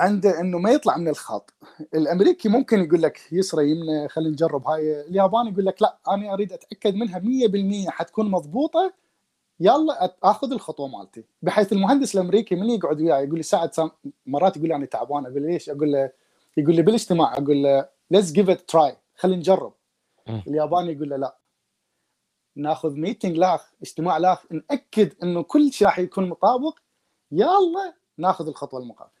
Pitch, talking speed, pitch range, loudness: 180 Hz, 160 wpm, 155-215 Hz, -22 LUFS